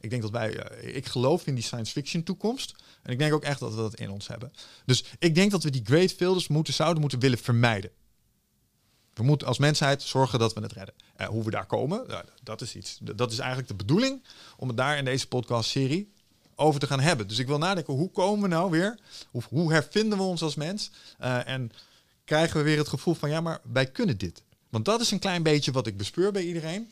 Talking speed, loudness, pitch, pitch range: 245 wpm, -27 LUFS, 140 Hz, 120-170 Hz